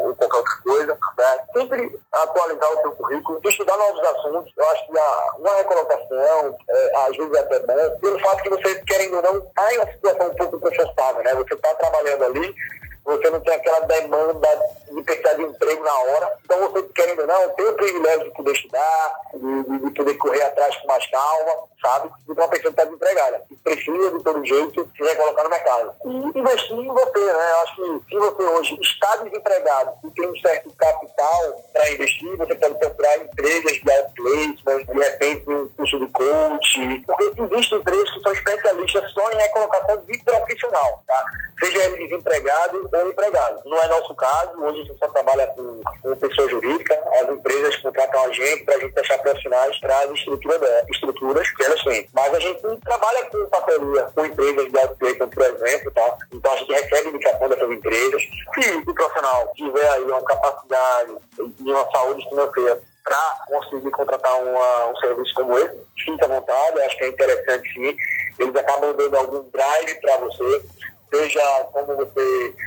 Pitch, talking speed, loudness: 190 Hz, 185 wpm, -20 LUFS